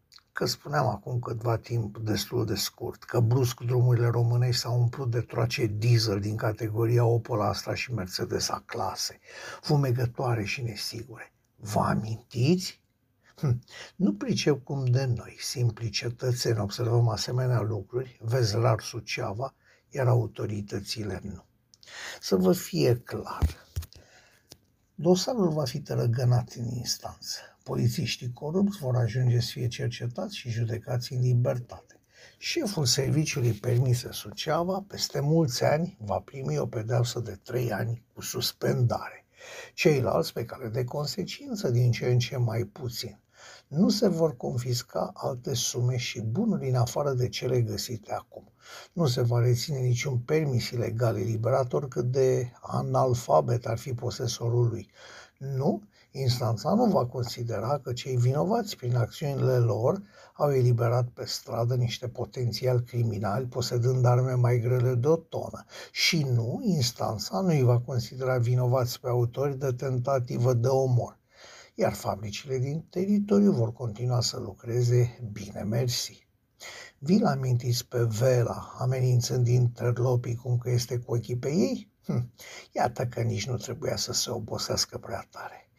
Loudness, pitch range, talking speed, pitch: -28 LUFS, 115-130 Hz, 135 wpm, 125 Hz